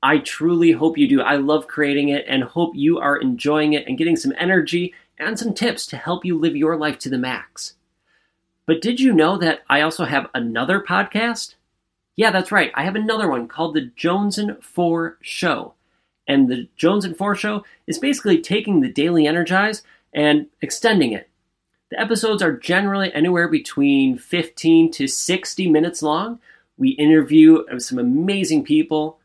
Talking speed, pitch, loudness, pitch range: 175 wpm, 170 Hz, -18 LUFS, 155-210 Hz